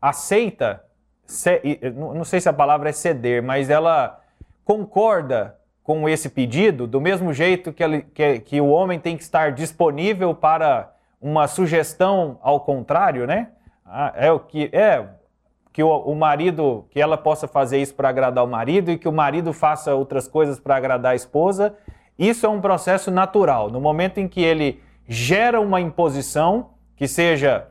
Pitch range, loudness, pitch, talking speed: 140-180 Hz, -19 LUFS, 155 Hz, 160 wpm